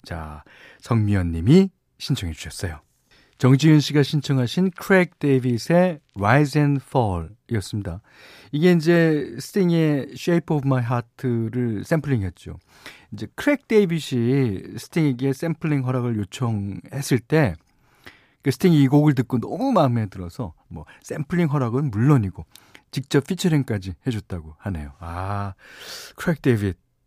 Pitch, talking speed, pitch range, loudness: 130 Hz, 315 characters per minute, 100-150 Hz, -21 LUFS